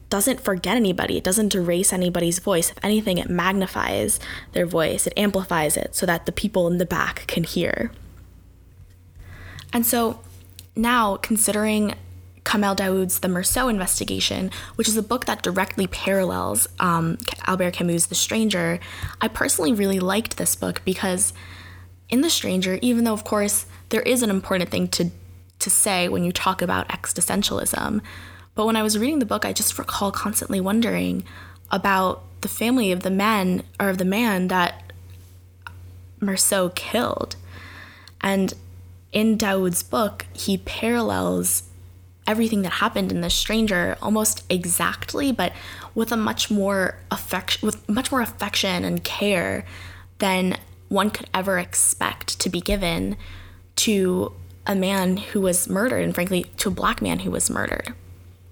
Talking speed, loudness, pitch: 150 wpm, -22 LUFS, 180 Hz